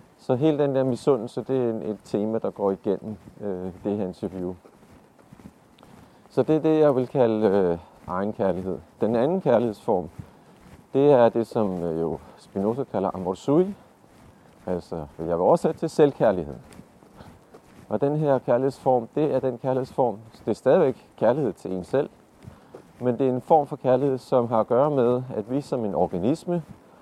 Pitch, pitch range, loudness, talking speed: 125 Hz, 100-140 Hz, -24 LUFS, 165 wpm